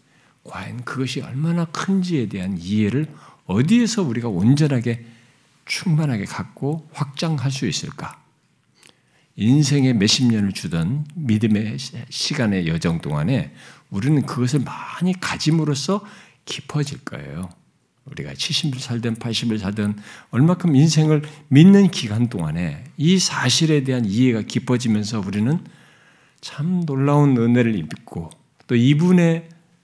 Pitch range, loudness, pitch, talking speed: 115-160 Hz, -20 LUFS, 140 Hz, 265 characters per minute